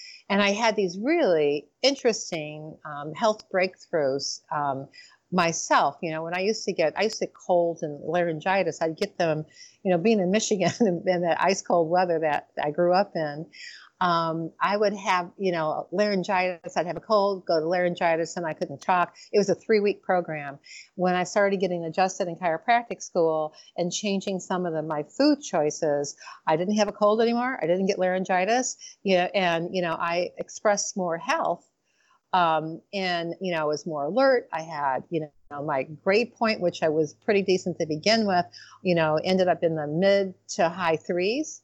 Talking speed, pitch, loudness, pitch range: 195 wpm, 180 Hz, -25 LUFS, 160-200 Hz